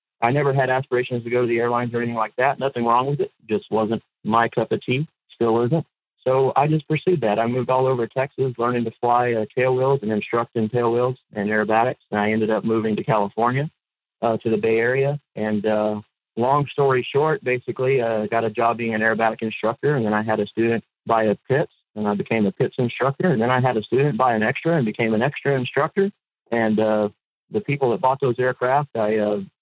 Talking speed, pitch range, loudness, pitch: 225 wpm, 110-130 Hz, -21 LUFS, 120 Hz